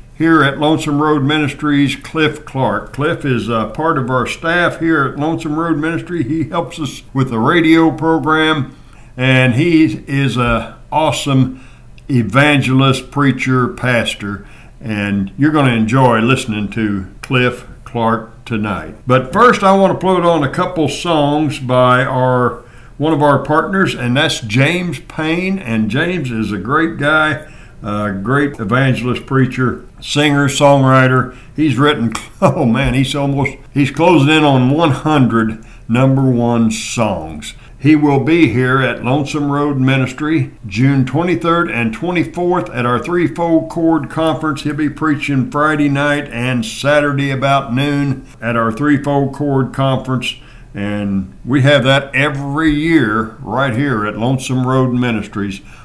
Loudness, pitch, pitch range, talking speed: -14 LUFS, 135 Hz, 125-155 Hz, 140 wpm